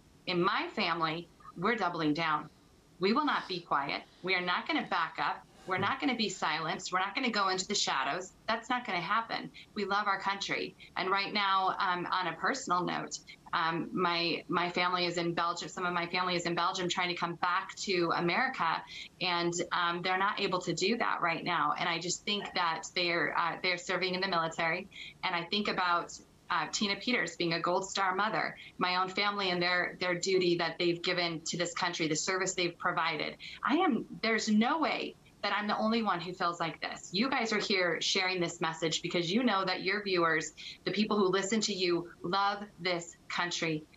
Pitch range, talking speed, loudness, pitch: 170-195 Hz, 215 wpm, -32 LUFS, 180 Hz